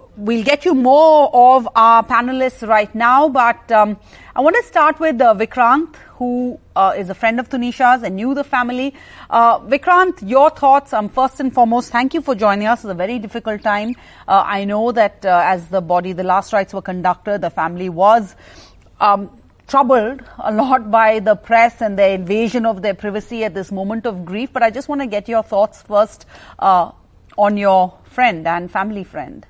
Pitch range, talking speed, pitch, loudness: 200-250 Hz, 195 wpm, 225 Hz, -15 LUFS